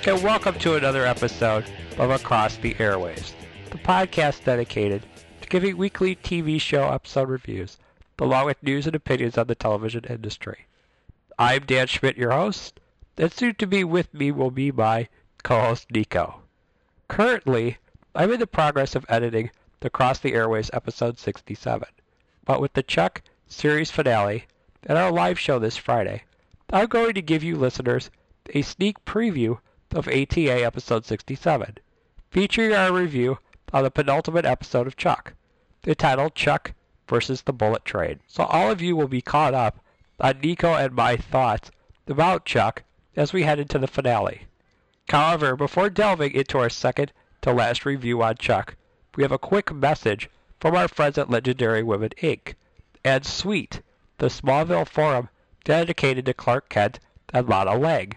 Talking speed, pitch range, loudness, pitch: 160 wpm, 115-155 Hz, -23 LUFS, 130 Hz